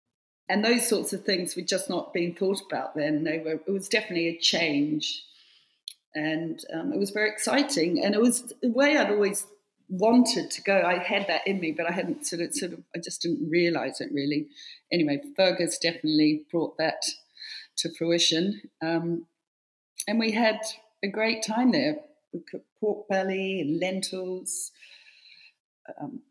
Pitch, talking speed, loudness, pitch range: 190 Hz, 170 wpm, -26 LUFS, 170-220 Hz